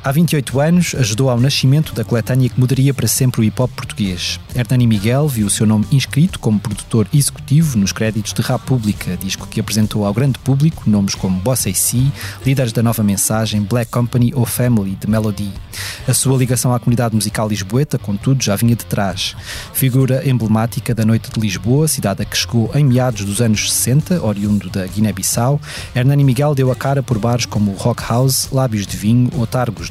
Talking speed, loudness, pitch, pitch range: 190 wpm, -16 LUFS, 120 Hz, 105-130 Hz